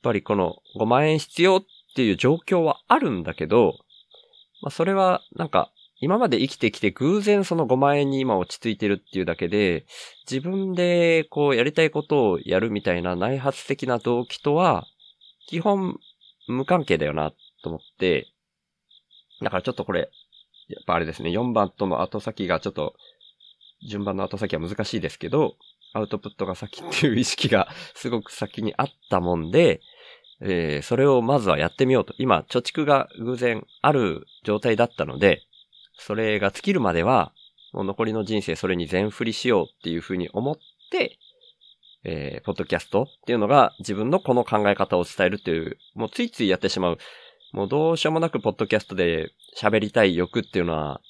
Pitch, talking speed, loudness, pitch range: 120 Hz, 355 characters per minute, -23 LUFS, 100-160 Hz